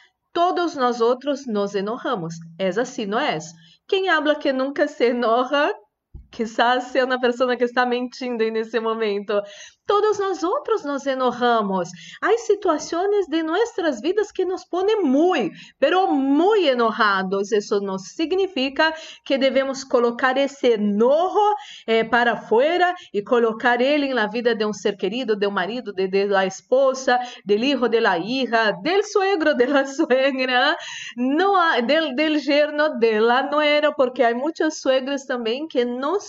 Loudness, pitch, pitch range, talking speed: -21 LUFS, 260 Hz, 230-315 Hz, 150 wpm